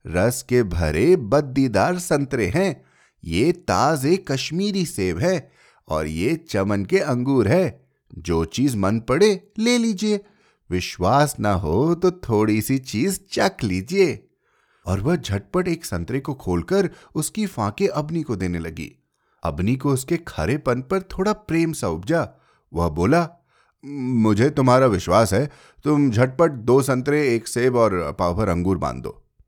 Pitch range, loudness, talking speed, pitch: 100-170 Hz, -21 LUFS, 145 wpm, 135 Hz